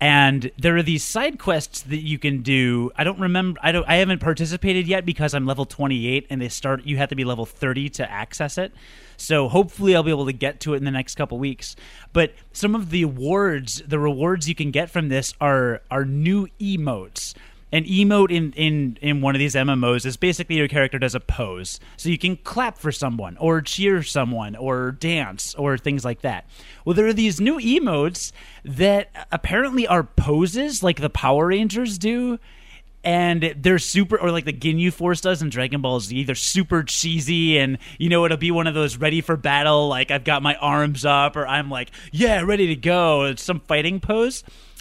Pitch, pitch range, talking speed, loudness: 150 Hz, 135-180 Hz, 210 wpm, -21 LUFS